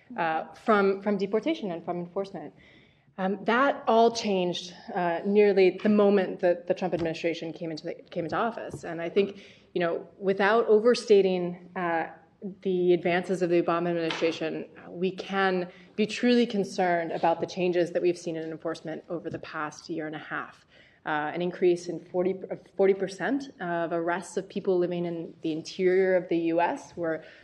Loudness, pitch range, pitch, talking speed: -27 LUFS, 170-195 Hz, 180 Hz, 170 wpm